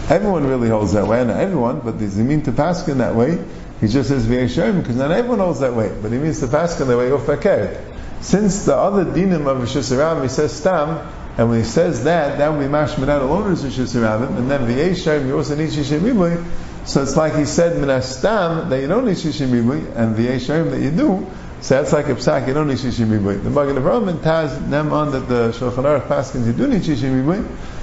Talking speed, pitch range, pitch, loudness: 225 wpm, 125-160 Hz, 145 Hz, -18 LUFS